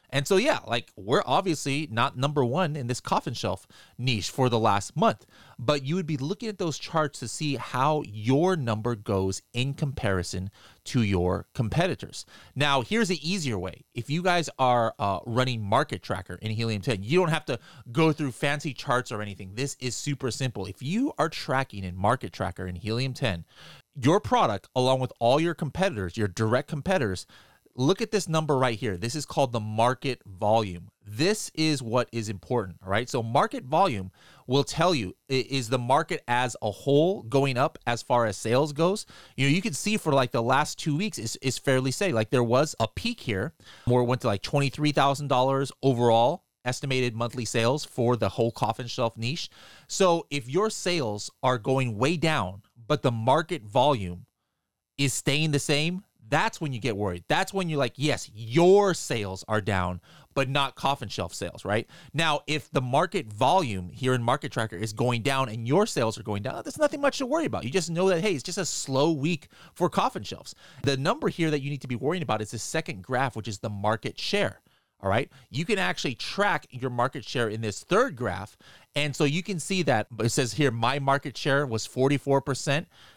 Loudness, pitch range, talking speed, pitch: -27 LUFS, 115-150 Hz, 200 wpm, 130 Hz